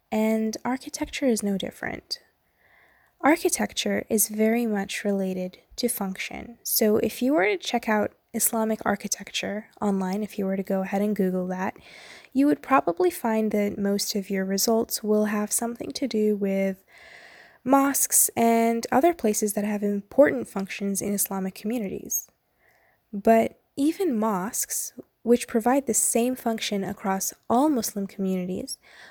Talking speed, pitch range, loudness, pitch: 140 wpm, 200-245 Hz, -25 LUFS, 220 Hz